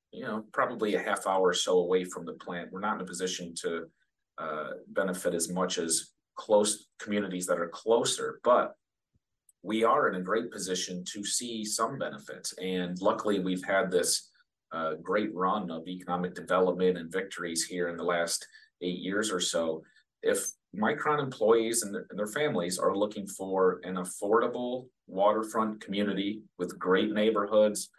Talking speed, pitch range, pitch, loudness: 165 wpm, 90-110 Hz, 100 Hz, -30 LUFS